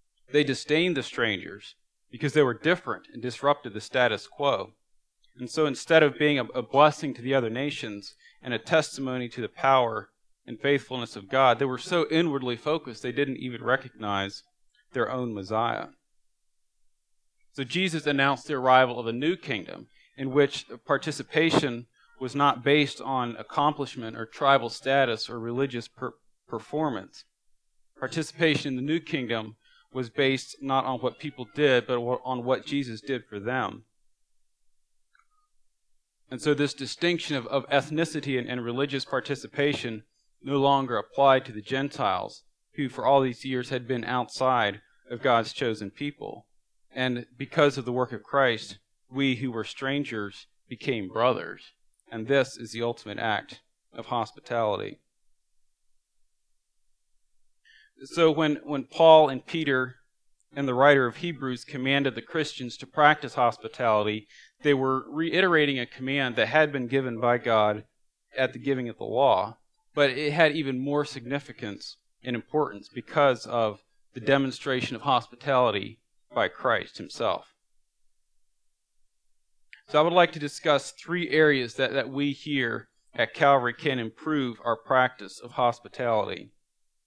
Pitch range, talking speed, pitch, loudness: 120-145 Hz, 145 wpm, 135 Hz, -26 LUFS